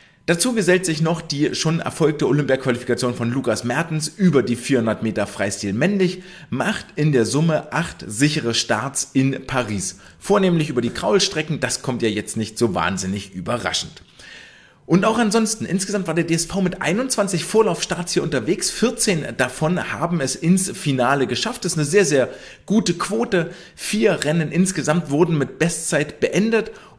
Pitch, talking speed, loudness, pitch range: 155 Hz, 160 wpm, -20 LUFS, 125-185 Hz